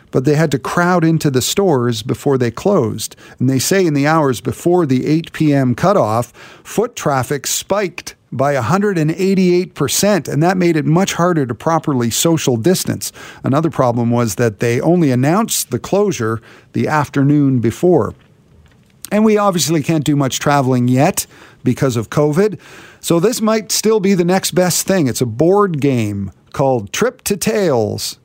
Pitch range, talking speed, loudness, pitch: 125-180 Hz, 165 wpm, -15 LUFS, 150 Hz